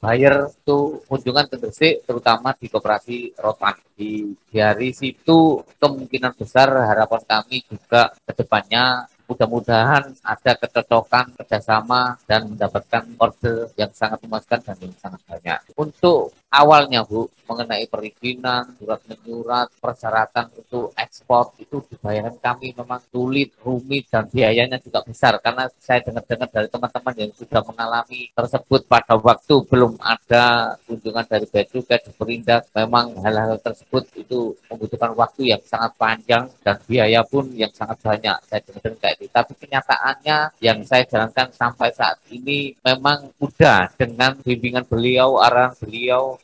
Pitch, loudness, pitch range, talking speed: 120 Hz, -19 LUFS, 110-130 Hz, 135 wpm